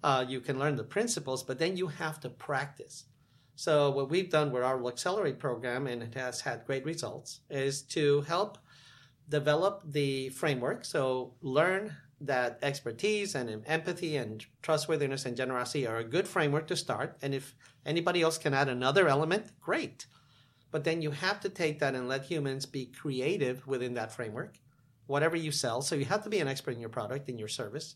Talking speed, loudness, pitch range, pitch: 190 wpm, -32 LUFS, 130-160 Hz, 140 Hz